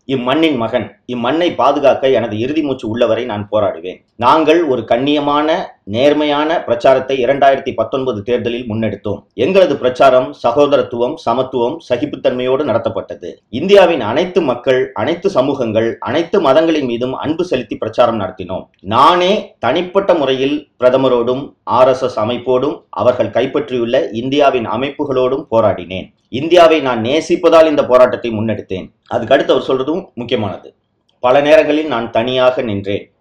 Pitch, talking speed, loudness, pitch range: 125 Hz, 115 wpm, -14 LUFS, 120-145 Hz